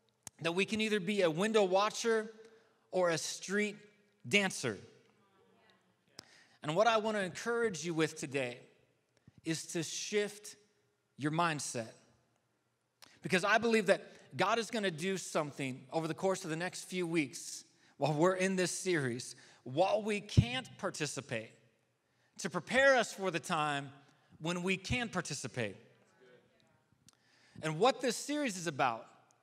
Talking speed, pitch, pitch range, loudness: 135 wpm, 180 Hz, 150-205 Hz, -34 LUFS